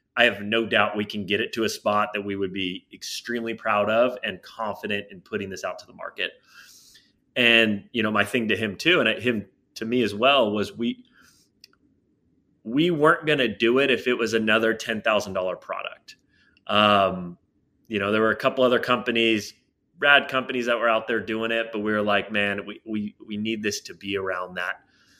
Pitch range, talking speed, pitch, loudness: 105-120 Hz, 205 wpm, 110 Hz, -23 LUFS